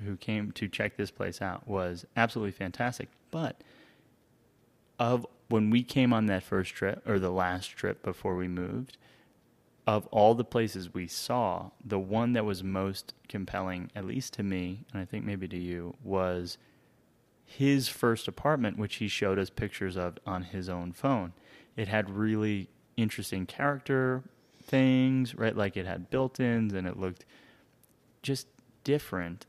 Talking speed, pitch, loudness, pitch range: 160 wpm, 105 Hz, -31 LUFS, 95-120 Hz